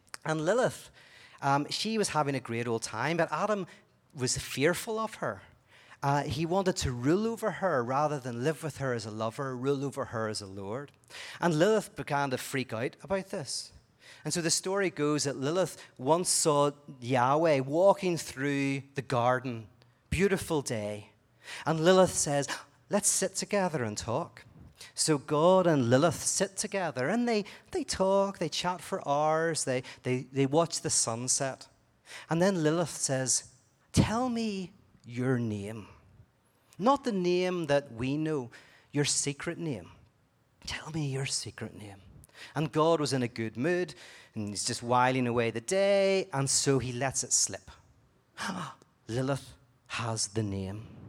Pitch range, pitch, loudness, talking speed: 120-170 Hz, 140 Hz, -30 LUFS, 160 wpm